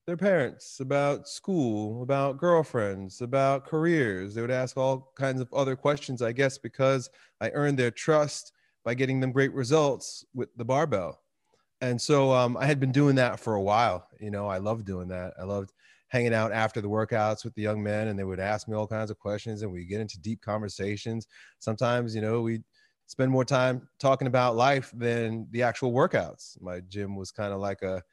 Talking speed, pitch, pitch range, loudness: 205 wpm, 120 Hz, 105-135 Hz, -28 LUFS